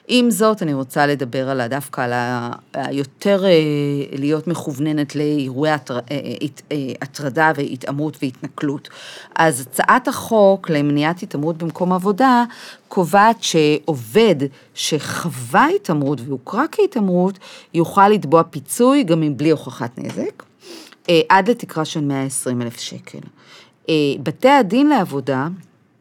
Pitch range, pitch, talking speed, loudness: 140-190 Hz, 155 Hz, 105 wpm, -18 LUFS